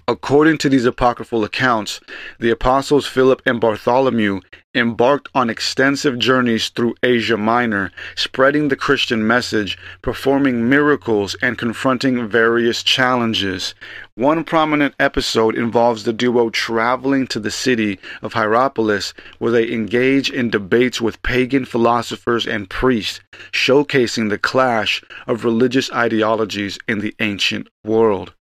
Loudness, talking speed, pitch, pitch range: -17 LUFS, 125 wpm, 120 Hz, 110-130 Hz